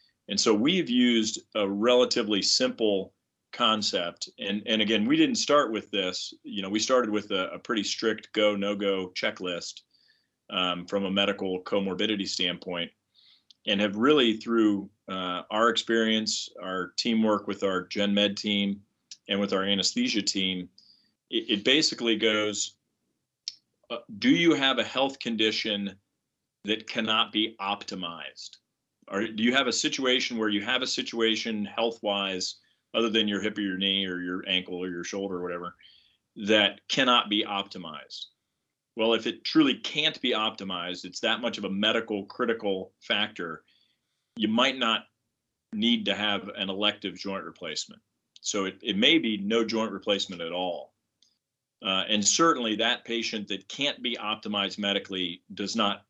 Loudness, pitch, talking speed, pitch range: -27 LUFS, 105 Hz, 155 wpm, 100-115 Hz